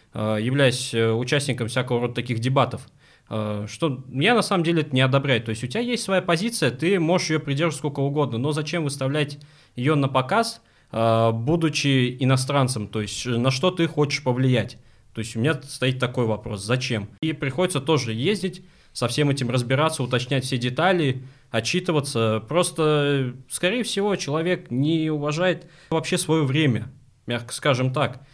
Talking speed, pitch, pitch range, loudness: 155 wpm, 140 Hz, 125-160 Hz, -23 LUFS